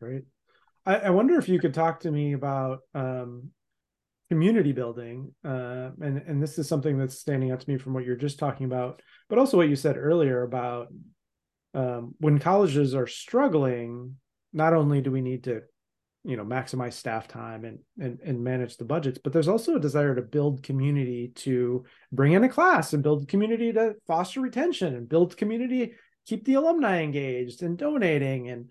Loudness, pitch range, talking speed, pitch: -26 LUFS, 125-170 Hz, 185 wpm, 140 Hz